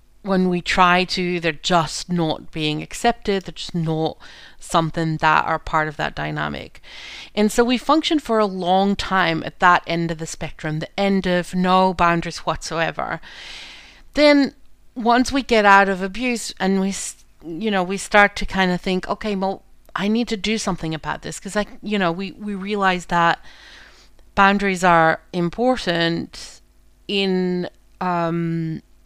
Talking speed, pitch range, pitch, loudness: 160 wpm, 170-205 Hz, 185 Hz, -20 LUFS